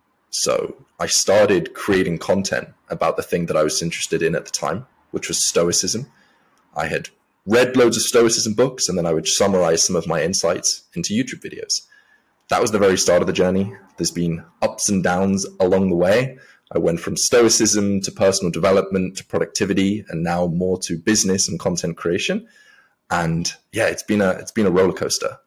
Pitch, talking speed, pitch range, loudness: 95 Hz, 190 wpm, 90-110 Hz, -19 LUFS